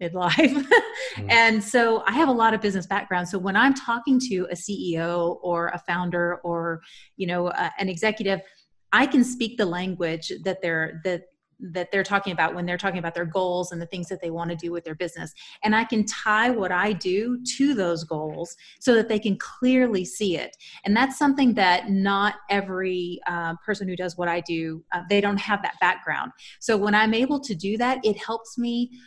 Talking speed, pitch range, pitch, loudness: 210 wpm, 175-225 Hz, 195 Hz, -24 LUFS